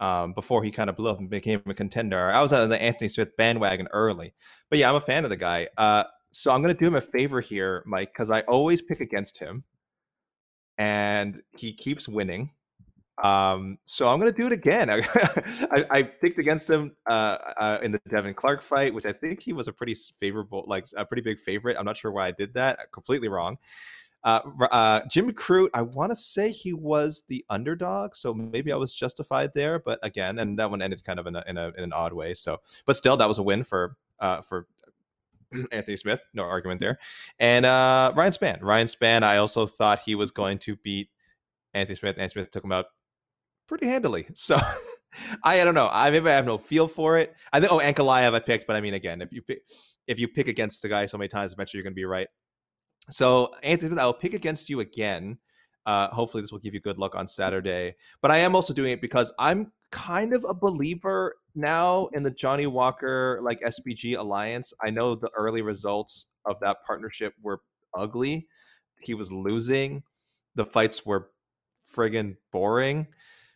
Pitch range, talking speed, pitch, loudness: 100-145 Hz, 210 wpm, 115 Hz, -25 LUFS